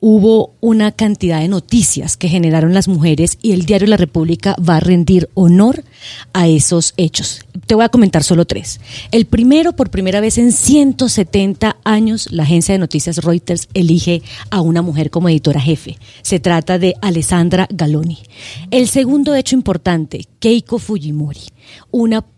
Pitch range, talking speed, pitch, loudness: 160-215 Hz, 160 wpm, 180 Hz, -13 LUFS